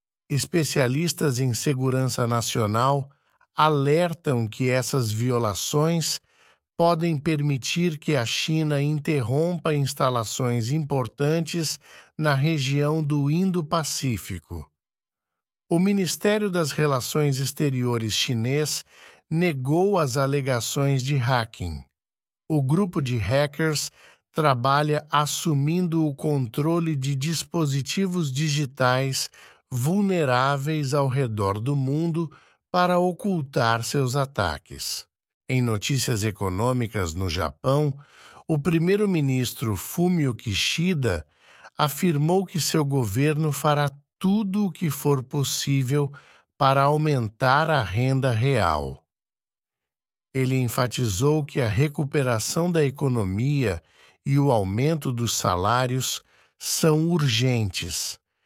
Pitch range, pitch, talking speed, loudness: 125-155 Hz, 140 Hz, 90 wpm, -24 LUFS